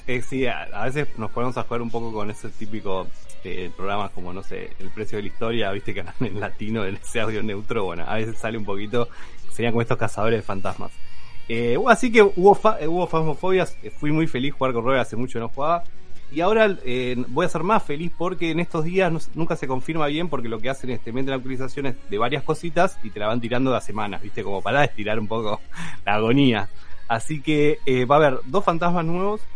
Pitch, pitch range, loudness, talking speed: 125 Hz, 110-155 Hz, -23 LUFS, 235 wpm